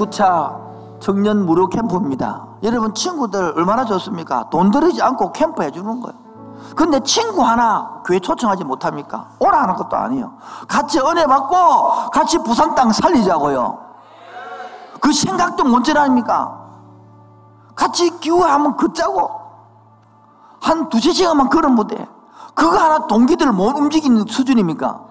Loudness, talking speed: -16 LUFS, 300 characters per minute